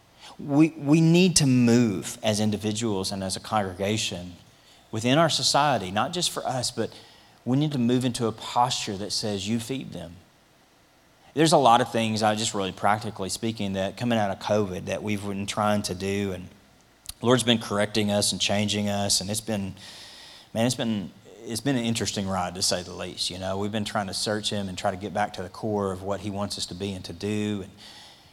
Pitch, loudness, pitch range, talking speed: 105 Hz, -25 LUFS, 100-115 Hz, 215 wpm